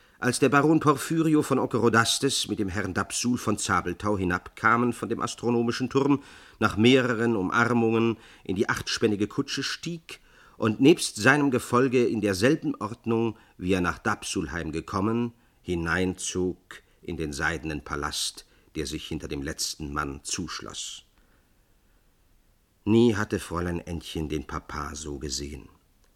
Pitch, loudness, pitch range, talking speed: 105 Hz, -26 LUFS, 85-120 Hz, 130 wpm